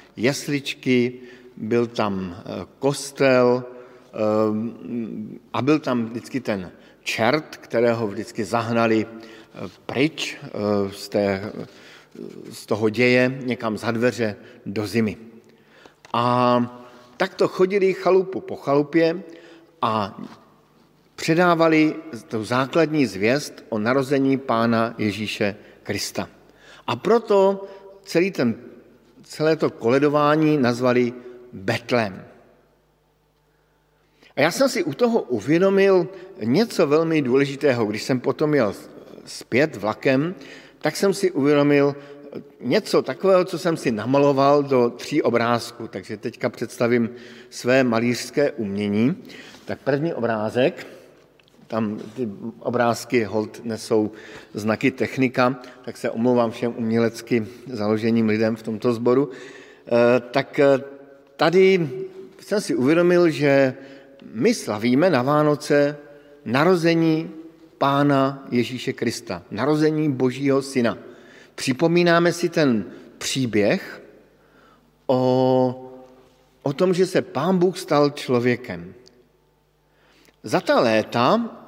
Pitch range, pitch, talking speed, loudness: 115-150 Hz, 130 Hz, 100 wpm, -21 LUFS